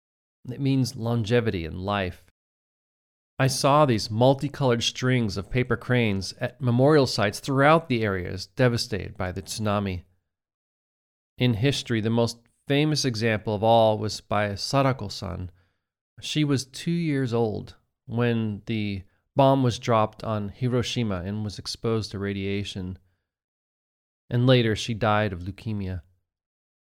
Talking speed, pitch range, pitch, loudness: 125 wpm, 95-125 Hz, 110 Hz, -25 LUFS